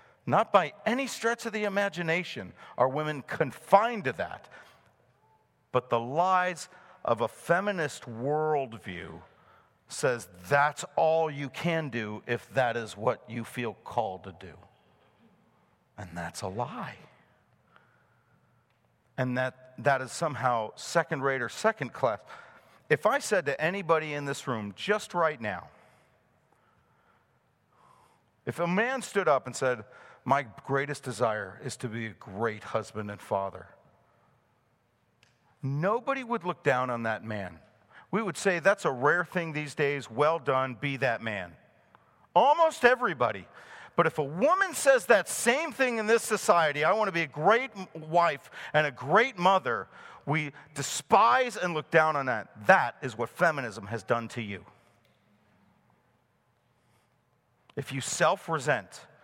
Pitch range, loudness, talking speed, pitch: 115-180 Hz, -28 LUFS, 140 wpm, 140 Hz